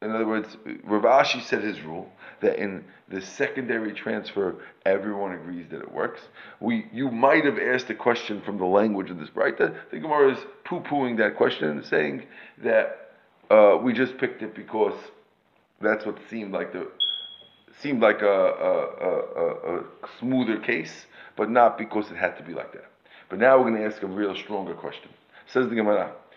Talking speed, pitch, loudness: 185 wpm, 115 Hz, -24 LUFS